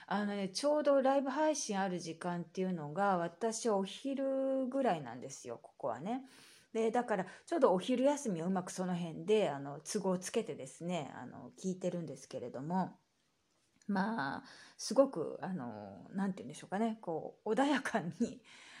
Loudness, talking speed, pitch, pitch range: -36 LUFS, 330 characters per minute, 200 Hz, 180-245 Hz